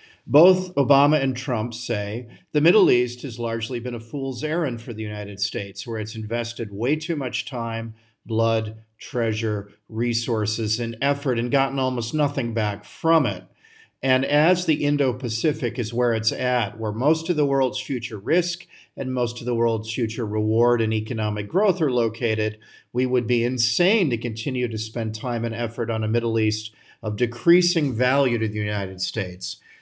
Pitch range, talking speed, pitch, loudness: 110-135 Hz, 175 wpm, 120 Hz, -23 LUFS